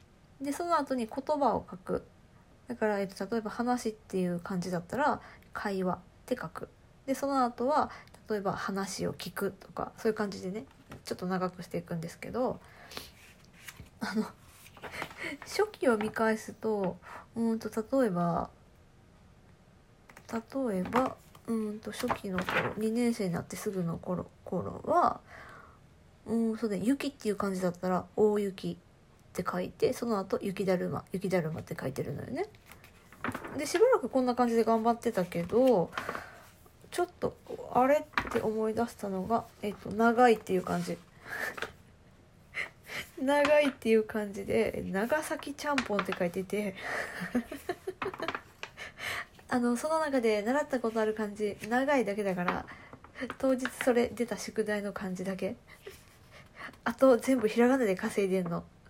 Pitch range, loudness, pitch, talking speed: 195-255 Hz, -32 LUFS, 220 Hz, 270 characters per minute